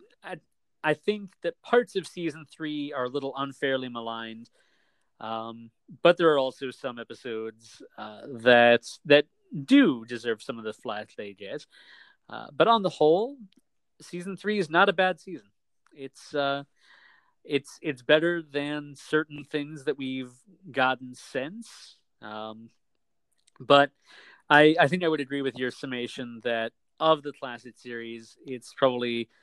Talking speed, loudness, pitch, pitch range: 145 wpm, -26 LUFS, 140 Hz, 120-160 Hz